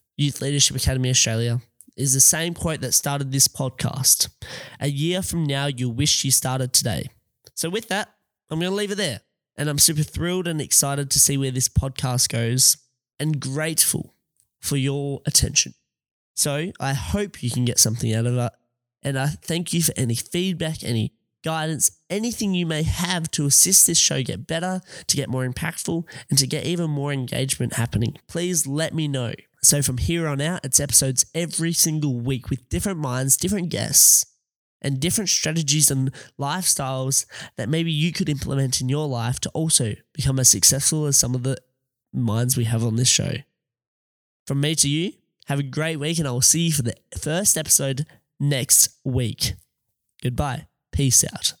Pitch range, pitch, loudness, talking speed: 130-160 Hz, 140 Hz, -20 LUFS, 180 wpm